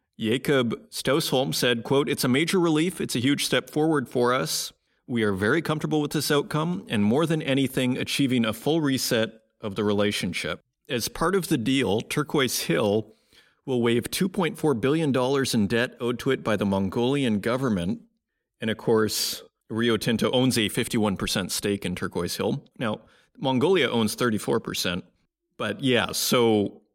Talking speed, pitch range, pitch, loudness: 175 wpm, 110-145 Hz, 125 Hz, -25 LUFS